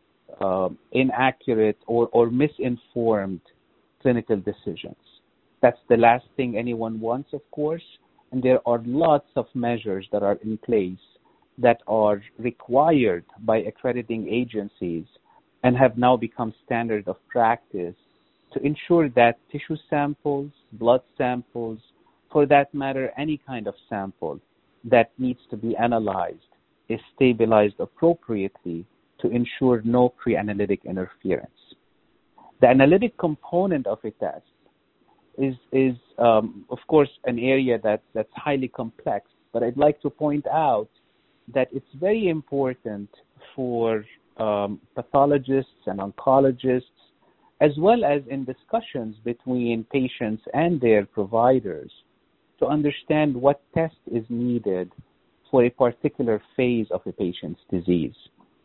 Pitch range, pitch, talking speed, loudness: 115-140 Hz, 125 Hz, 125 wpm, -23 LUFS